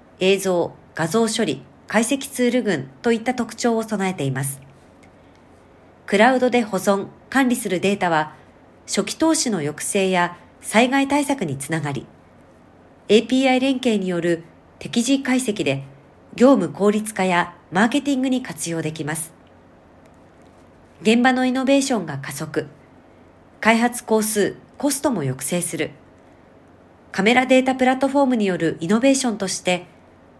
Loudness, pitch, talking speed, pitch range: -20 LUFS, 200 Hz, 280 characters per minute, 160-250 Hz